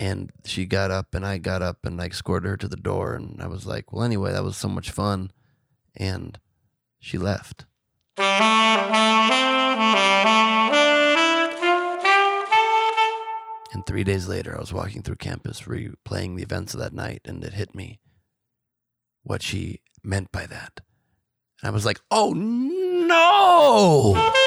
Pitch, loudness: 120 Hz, -20 LUFS